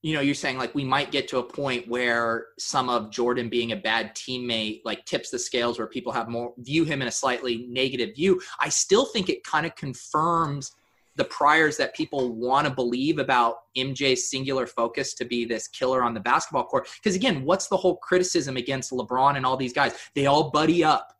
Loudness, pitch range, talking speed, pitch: -25 LUFS, 120-145 Hz, 215 wpm, 130 Hz